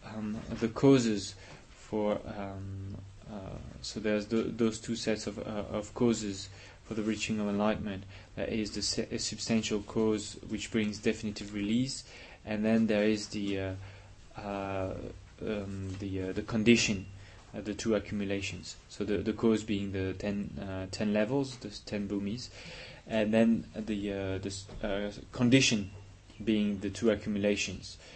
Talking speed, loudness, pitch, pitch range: 155 wpm, -32 LUFS, 105 Hz, 100-110 Hz